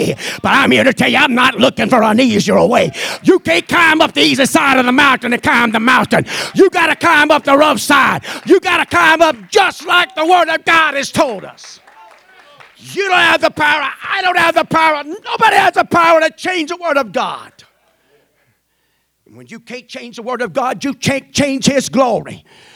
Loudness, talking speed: -12 LUFS, 220 wpm